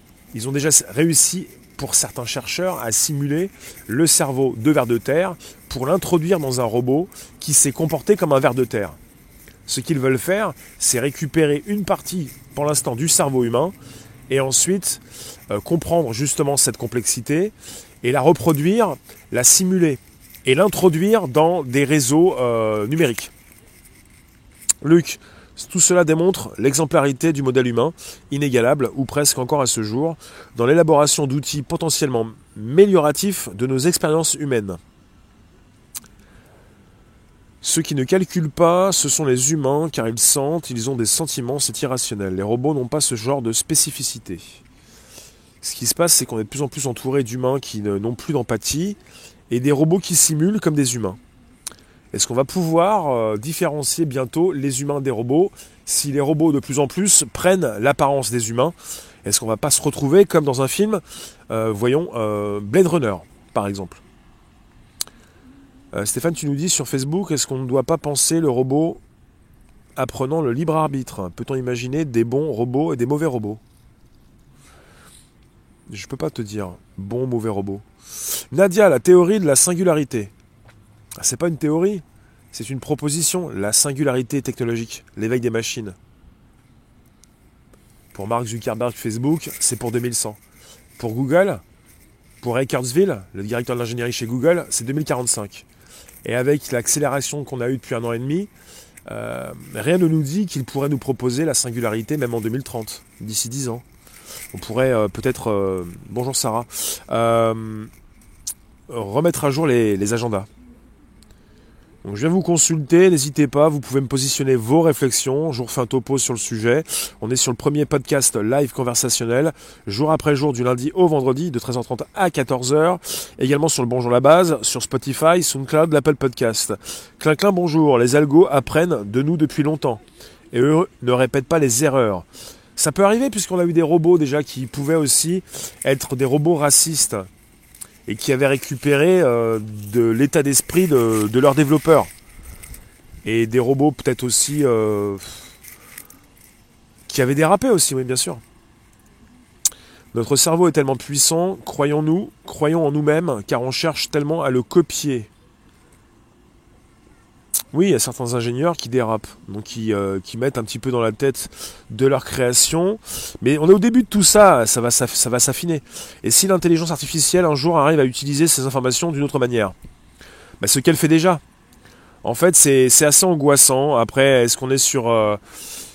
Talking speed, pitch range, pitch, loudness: 165 wpm, 120-160 Hz, 135 Hz, -18 LUFS